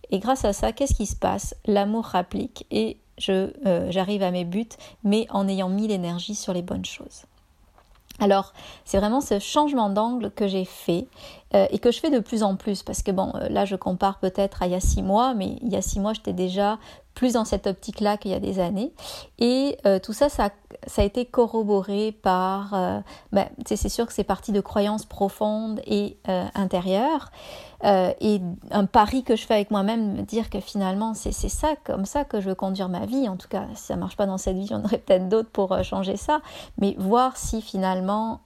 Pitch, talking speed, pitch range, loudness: 205 Hz, 225 wpm, 195-225 Hz, -24 LUFS